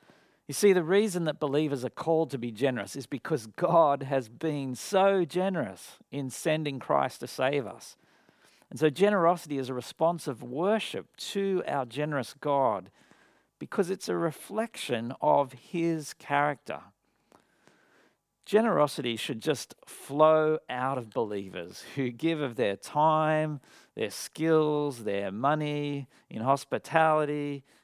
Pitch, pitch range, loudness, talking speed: 150 Hz, 135-165 Hz, -29 LUFS, 130 wpm